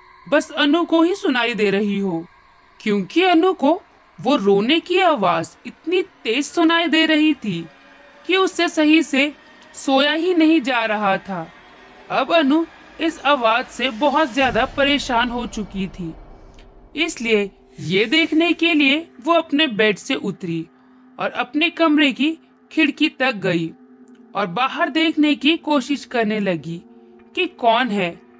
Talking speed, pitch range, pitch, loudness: 145 wpm, 215-320 Hz, 280 Hz, -18 LUFS